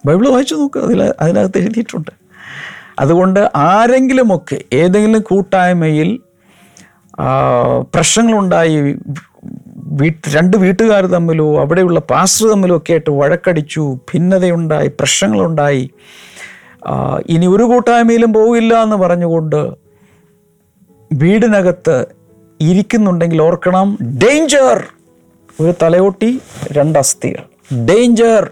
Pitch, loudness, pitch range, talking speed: 180 Hz, -12 LUFS, 155-220 Hz, 75 wpm